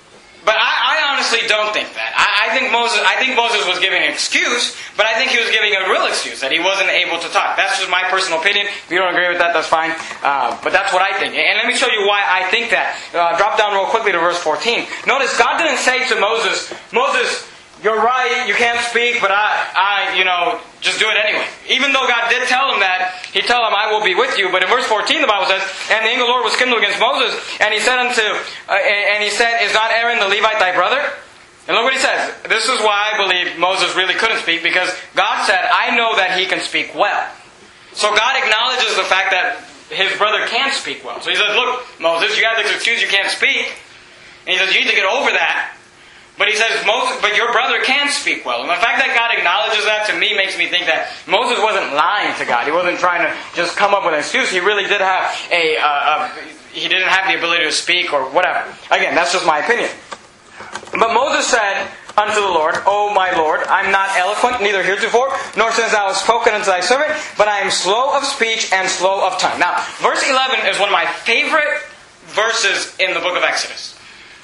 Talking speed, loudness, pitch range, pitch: 240 wpm, -15 LUFS, 185-235 Hz, 205 Hz